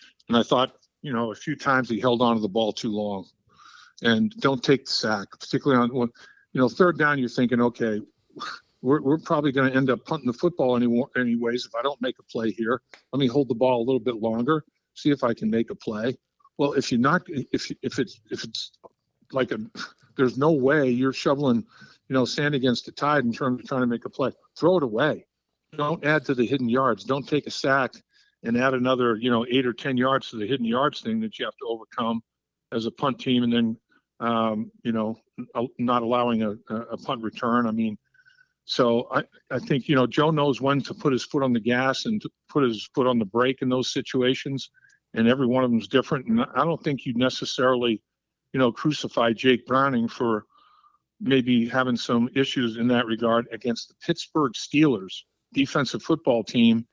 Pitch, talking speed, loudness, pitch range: 125 Hz, 215 wpm, -24 LUFS, 115-140 Hz